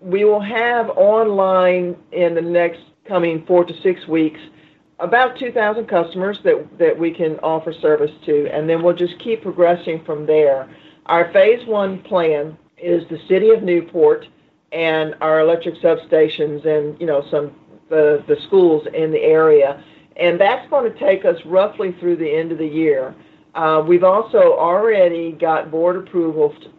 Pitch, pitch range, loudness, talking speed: 175 Hz, 155-205 Hz, -16 LUFS, 170 wpm